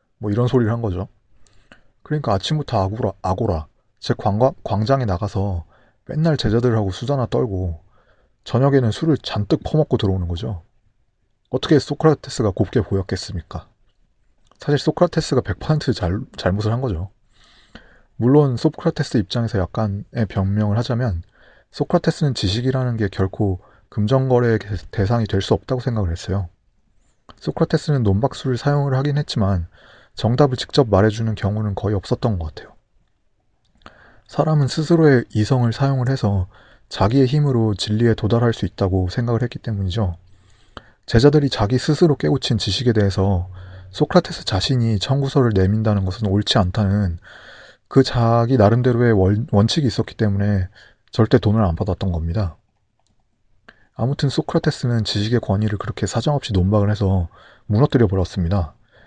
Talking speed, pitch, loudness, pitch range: 335 characters per minute, 110 Hz, -19 LUFS, 100-130 Hz